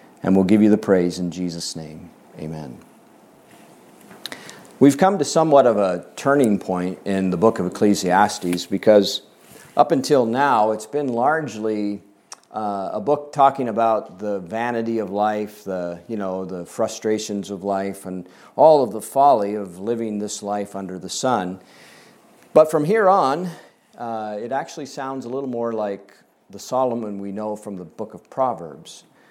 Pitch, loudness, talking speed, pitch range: 105 Hz, -20 LUFS, 160 wpm, 95-120 Hz